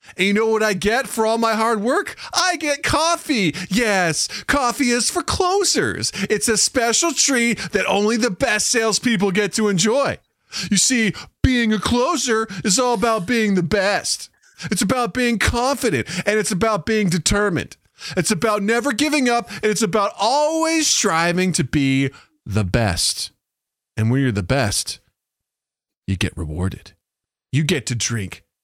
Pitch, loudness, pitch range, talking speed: 215 Hz, -19 LUFS, 180-240 Hz, 160 wpm